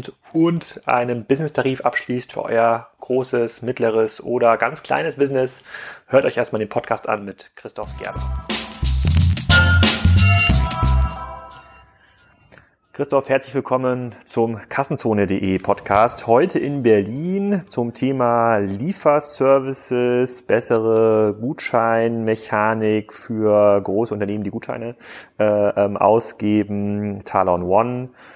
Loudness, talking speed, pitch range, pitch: -19 LUFS, 90 wpm, 100-125 Hz, 115 Hz